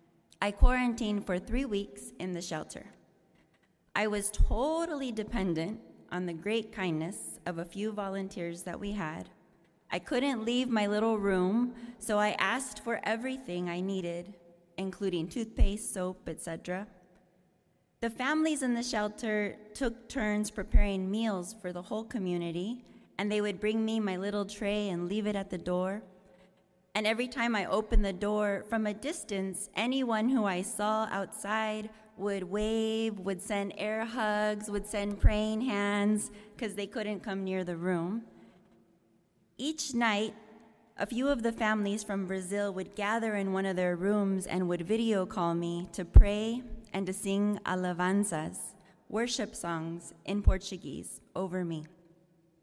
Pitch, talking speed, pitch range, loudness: 205 Hz, 150 wpm, 185-220 Hz, -33 LUFS